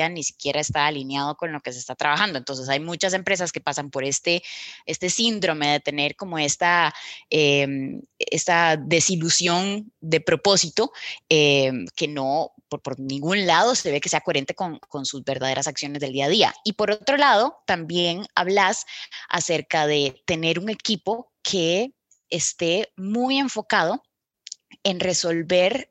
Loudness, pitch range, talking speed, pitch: -22 LUFS, 145-195 Hz, 155 wpm, 170 Hz